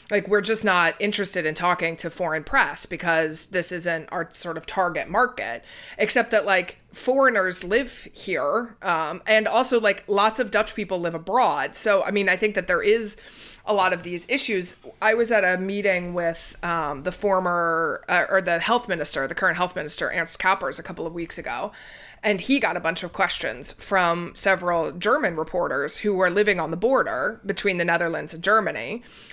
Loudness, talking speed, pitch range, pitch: -22 LUFS, 190 wpm, 170-210 Hz, 185 Hz